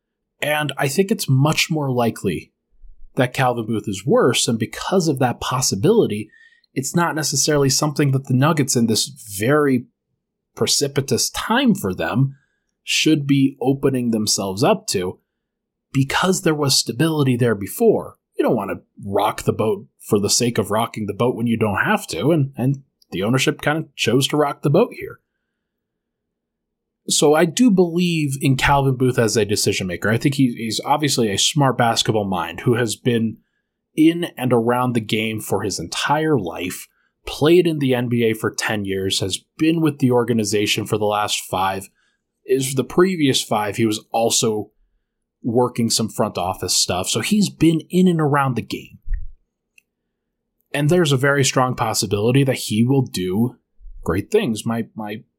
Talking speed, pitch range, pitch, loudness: 170 wpm, 110-150 Hz, 130 Hz, -19 LUFS